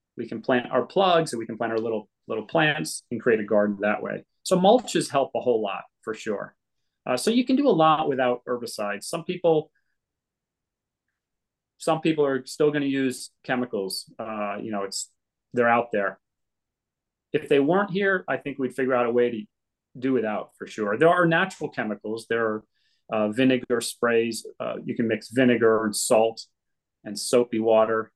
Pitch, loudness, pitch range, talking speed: 125 Hz, -24 LUFS, 110-145 Hz, 190 wpm